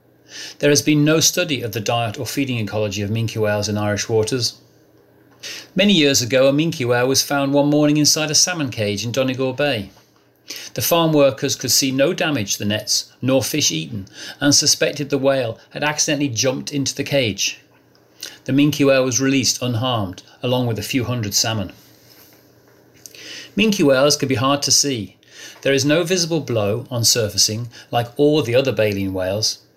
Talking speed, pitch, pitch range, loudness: 180 wpm, 130 Hz, 115-145 Hz, -18 LUFS